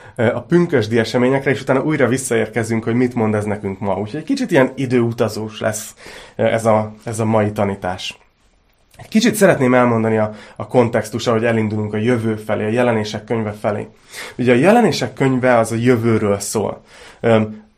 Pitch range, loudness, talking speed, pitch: 110-125 Hz, -17 LUFS, 160 wpm, 115 Hz